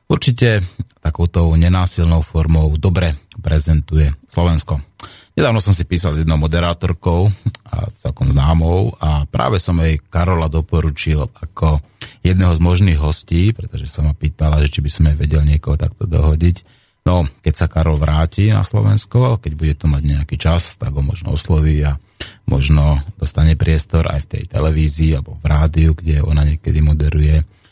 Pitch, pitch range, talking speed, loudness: 80 Hz, 75-95 Hz, 155 wpm, -16 LUFS